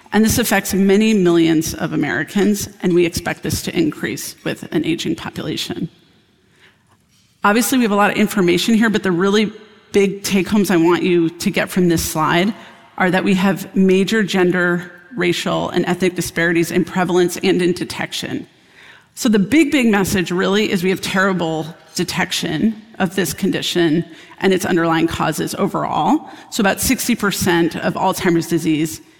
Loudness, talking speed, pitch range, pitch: -17 LUFS, 160 wpm, 175-200 Hz, 185 Hz